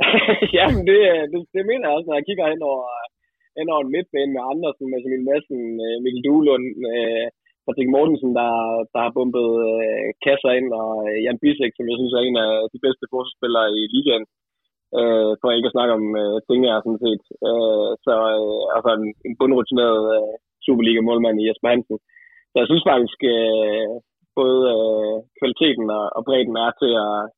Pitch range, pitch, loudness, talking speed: 110-140 Hz, 120 Hz, -19 LUFS, 185 wpm